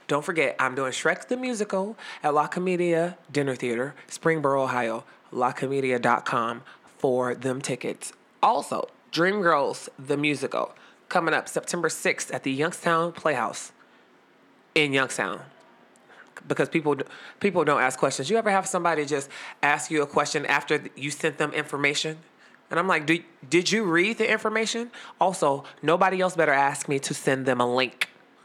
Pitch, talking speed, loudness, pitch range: 150 Hz, 150 wpm, -25 LUFS, 135-175 Hz